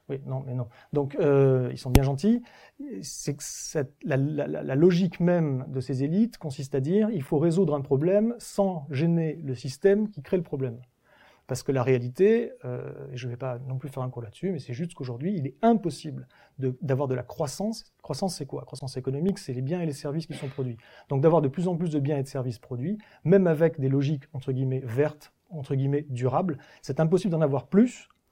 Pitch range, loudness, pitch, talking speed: 130-175 Hz, -27 LUFS, 145 Hz, 225 wpm